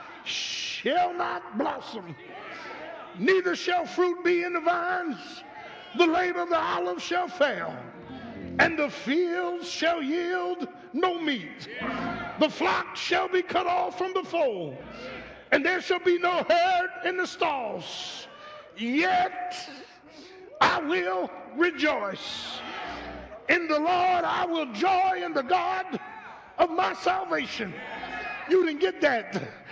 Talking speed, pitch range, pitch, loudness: 125 wpm, 310-360 Hz, 350 Hz, -27 LUFS